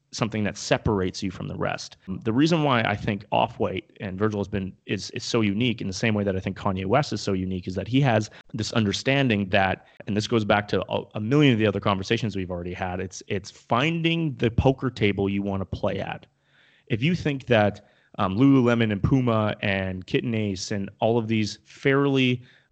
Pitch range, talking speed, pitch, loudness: 100-125 Hz, 215 wpm, 110 Hz, -25 LUFS